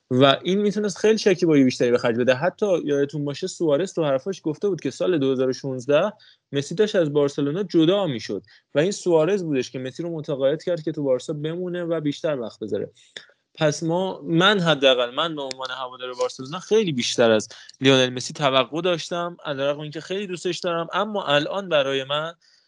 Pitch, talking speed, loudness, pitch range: 155 Hz, 185 wpm, -22 LUFS, 135-180 Hz